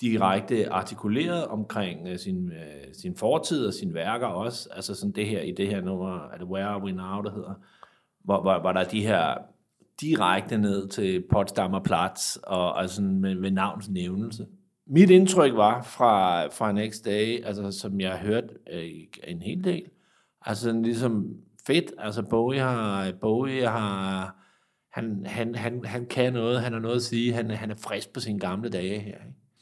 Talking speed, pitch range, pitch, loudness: 175 wpm, 95-120 Hz, 105 Hz, -26 LUFS